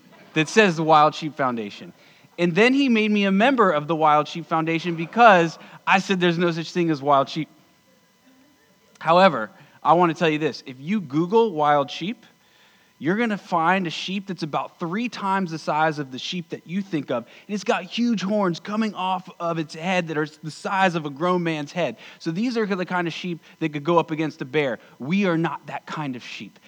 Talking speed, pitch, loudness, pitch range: 225 wpm, 175 Hz, -22 LUFS, 155-200 Hz